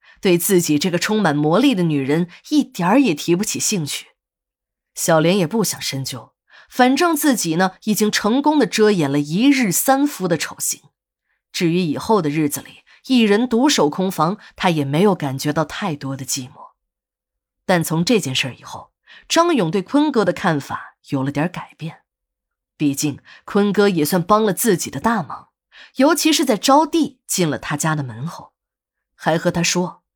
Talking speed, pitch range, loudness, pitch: 250 characters per minute, 155-230 Hz, -18 LUFS, 180 Hz